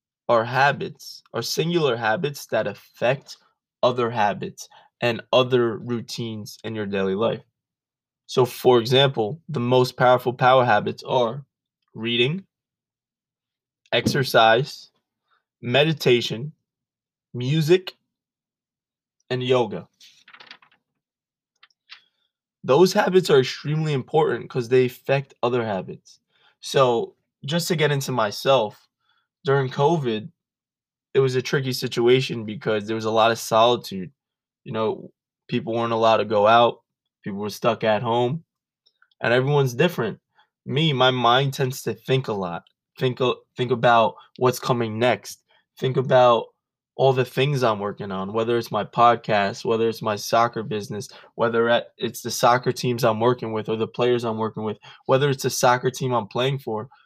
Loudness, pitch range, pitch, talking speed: -22 LUFS, 115-135 Hz, 125 Hz, 135 wpm